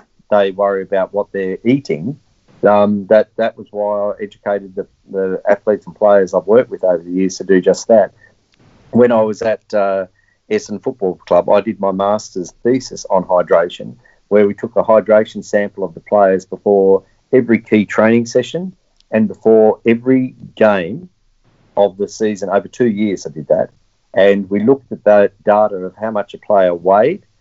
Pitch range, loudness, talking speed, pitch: 100-115 Hz, -15 LUFS, 180 wpm, 105 Hz